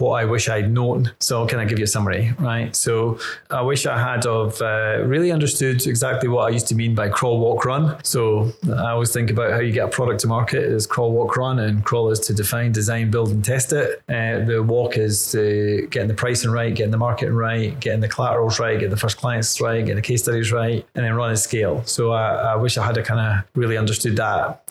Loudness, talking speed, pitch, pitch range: -20 LUFS, 250 wpm, 115 Hz, 110-120 Hz